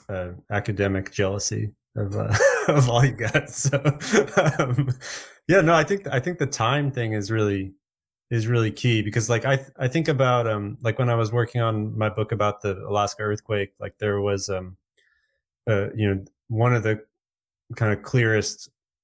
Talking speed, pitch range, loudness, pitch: 180 wpm, 105-130 Hz, -23 LUFS, 110 Hz